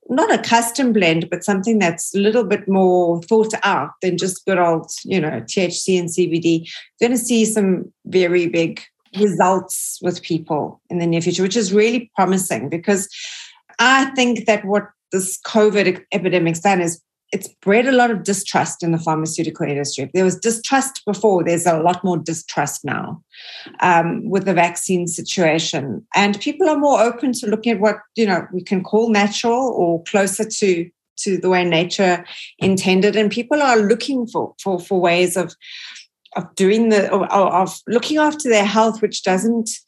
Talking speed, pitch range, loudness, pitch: 175 wpm, 175-220 Hz, -18 LUFS, 190 Hz